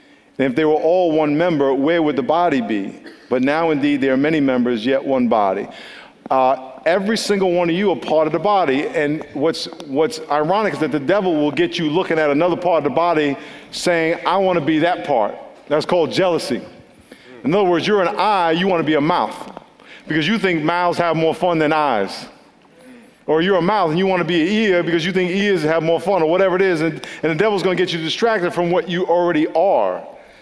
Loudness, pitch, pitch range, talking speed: -18 LUFS, 165 Hz, 150-180 Hz, 235 wpm